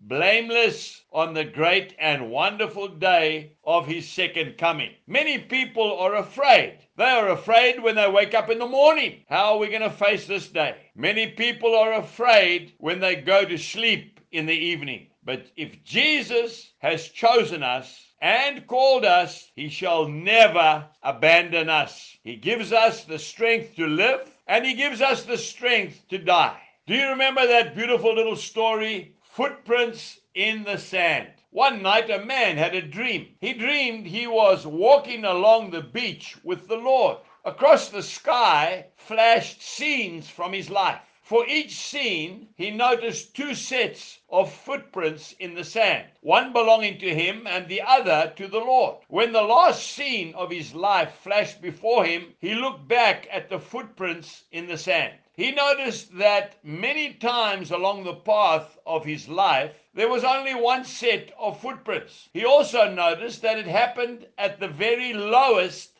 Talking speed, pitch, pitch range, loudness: 165 wpm, 215 Hz, 175-240 Hz, -22 LUFS